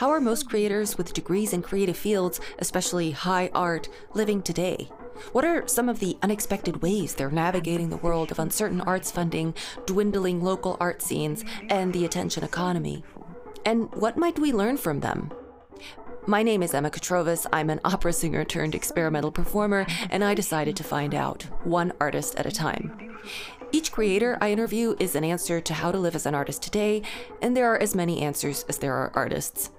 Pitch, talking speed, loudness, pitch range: 185 Hz, 185 wpm, -26 LUFS, 170-210 Hz